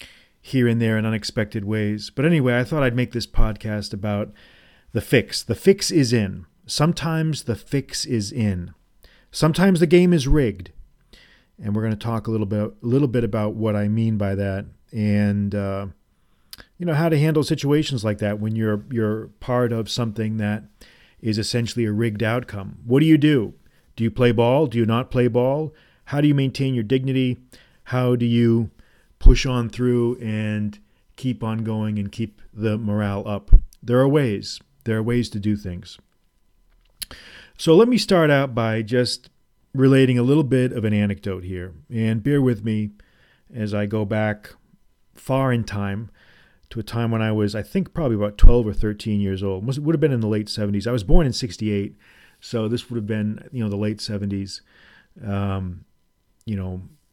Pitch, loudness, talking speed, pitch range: 110 Hz, -22 LUFS, 190 wpm, 105-125 Hz